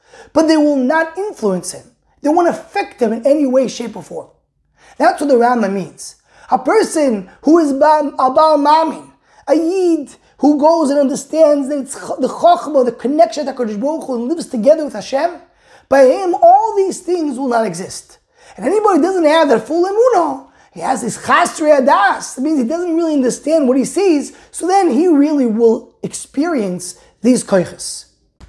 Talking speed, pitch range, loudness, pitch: 180 wpm, 255-335 Hz, -14 LUFS, 295 Hz